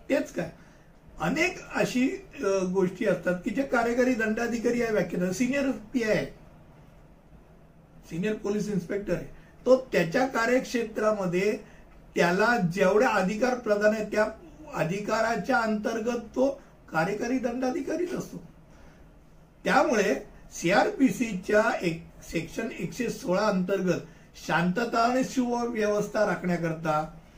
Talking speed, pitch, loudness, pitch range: 90 wpm, 215 Hz, -27 LUFS, 190-250 Hz